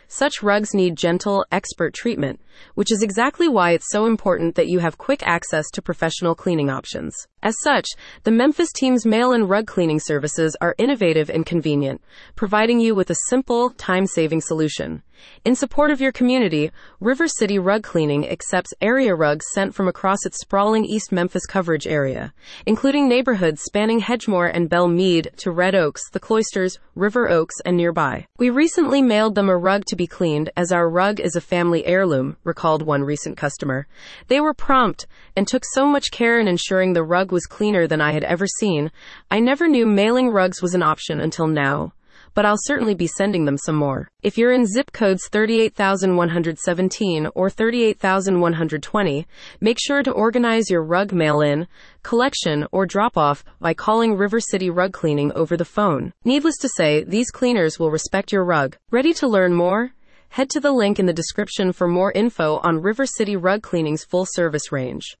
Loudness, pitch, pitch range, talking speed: -19 LUFS, 190 Hz, 165-225 Hz, 180 wpm